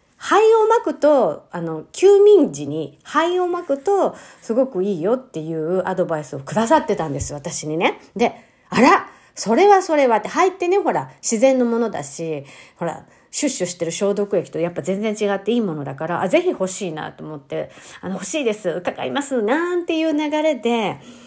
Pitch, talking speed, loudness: 225 Hz, 360 characters per minute, -19 LUFS